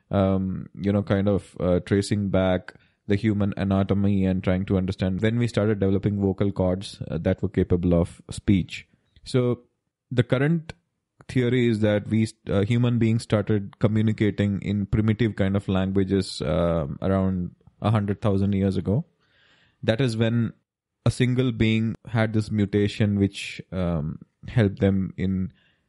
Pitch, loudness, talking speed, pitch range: 100 Hz, -24 LUFS, 155 wpm, 95-110 Hz